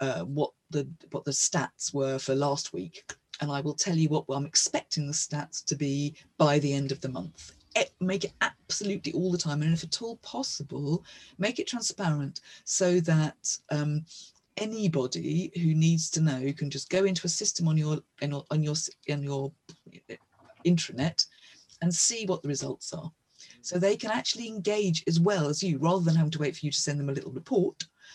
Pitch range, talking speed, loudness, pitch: 145-180 Hz, 200 wpm, -29 LUFS, 155 Hz